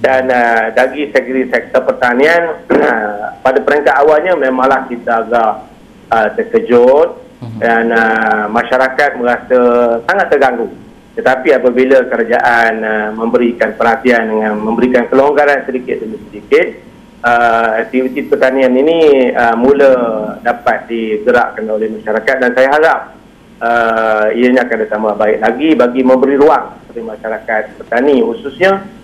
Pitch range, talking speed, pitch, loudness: 115-130 Hz, 125 wpm, 120 Hz, -11 LUFS